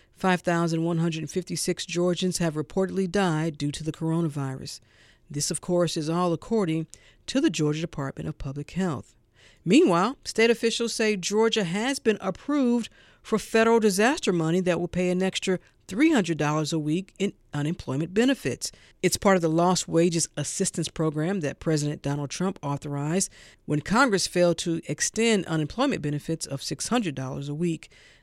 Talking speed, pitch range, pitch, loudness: 145 wpm, 150-195 Hz, 170 Hz, -26 LUFS